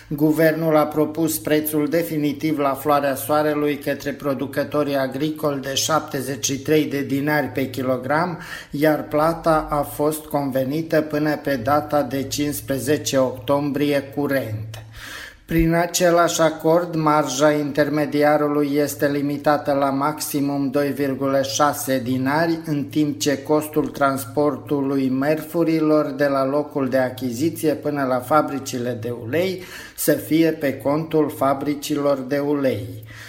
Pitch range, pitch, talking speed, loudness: 135-150 Hz, 145 Hz, 115 wpm, -21 LUFS